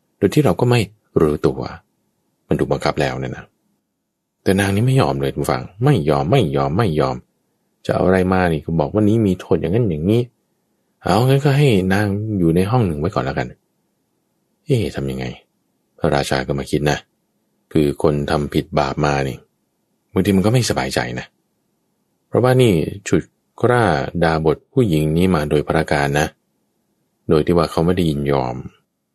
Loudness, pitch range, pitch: -18 LUFS, 70-100 Hz, 80 Hz